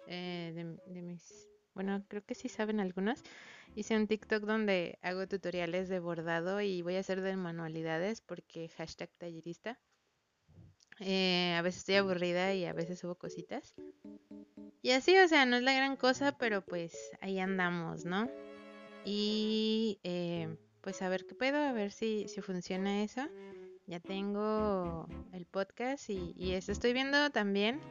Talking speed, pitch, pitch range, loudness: 160 wpm, 190 Hz, 175-215 Hz, -34 LUFS